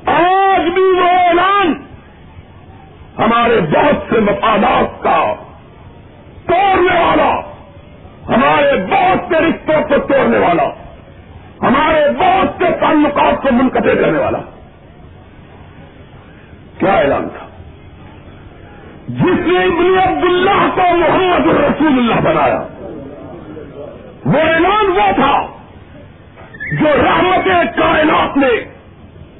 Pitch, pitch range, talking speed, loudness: 335 Hz, 280-365 Hz, 95 wpm, -12 LUFS